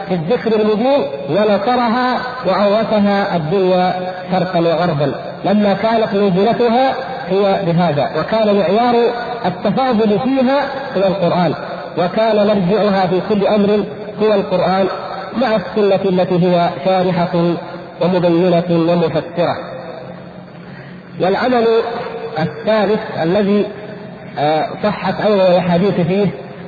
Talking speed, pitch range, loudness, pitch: 90 wpm, 175-215 Hz, -15 LUFS, 195 Hz